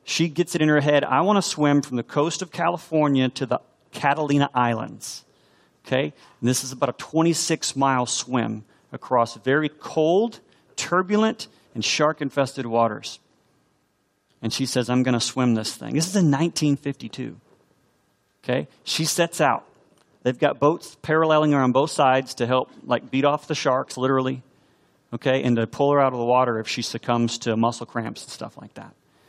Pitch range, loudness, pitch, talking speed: 125-155 Hz, -22 LUFS, 135 Hz, 180 wpm